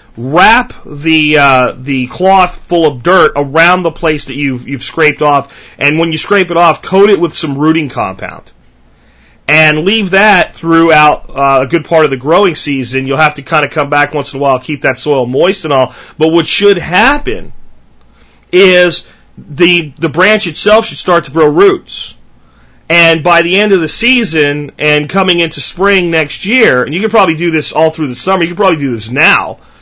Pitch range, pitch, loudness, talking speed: 145-180 Hz, 160 Hz, -9 LUFS, 200 wpm